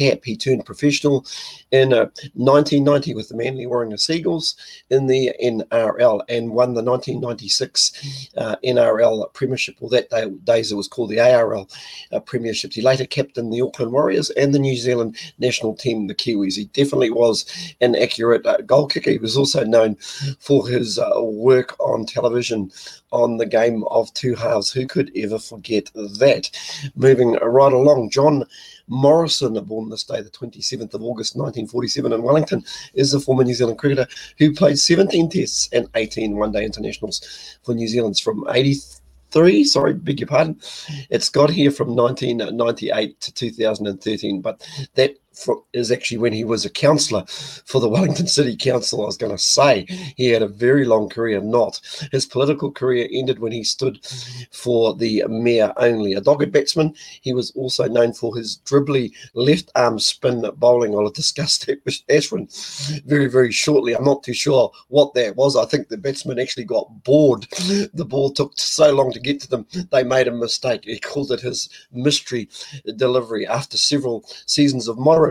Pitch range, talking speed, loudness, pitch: 115-140 Hz, 175 wpm, -19 LUFS, 125 Hz